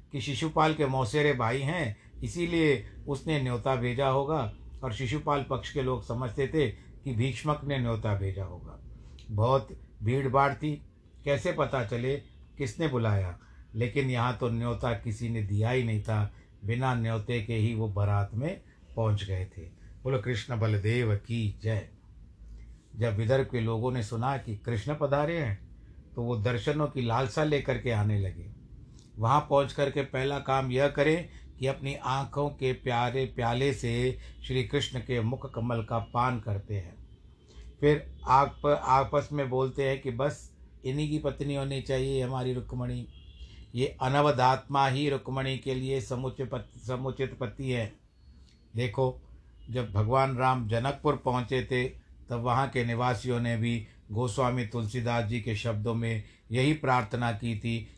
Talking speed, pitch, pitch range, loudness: 160 wpm, 125 Hz, 115-135 Hz, -30 LUFS